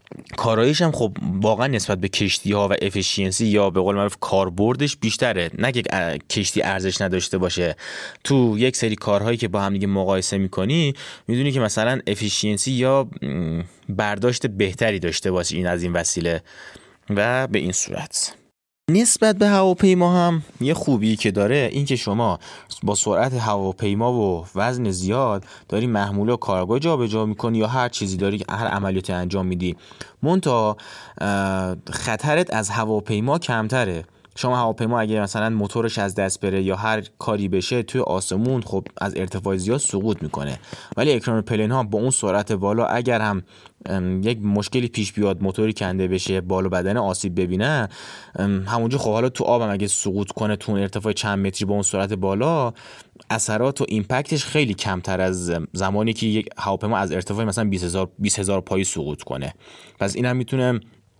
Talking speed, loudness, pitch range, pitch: 165 wpm, -22 LUFS, 95-120 Hz, 105 Hz